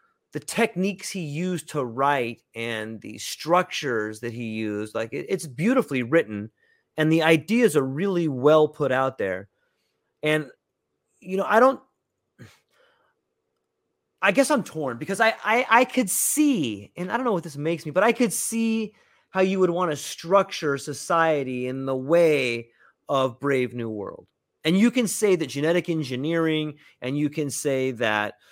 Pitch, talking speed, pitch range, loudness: 160 Hz, 165 wpm, 130-195 Hz, -24 LUFS